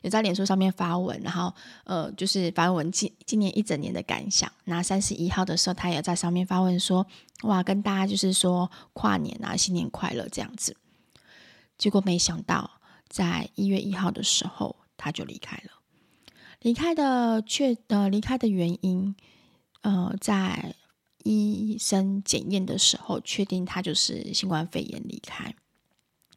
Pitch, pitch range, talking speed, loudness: 195 Hz, 180-210 Hz, 240 characters per minute, -26 LUFS